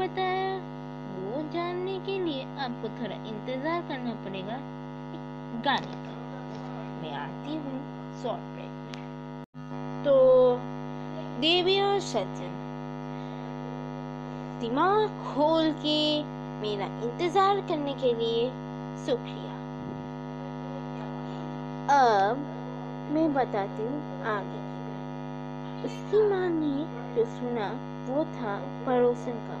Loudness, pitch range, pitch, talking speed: -30 LUFS, 240-360 Hz, 300 Hz, 75 wpm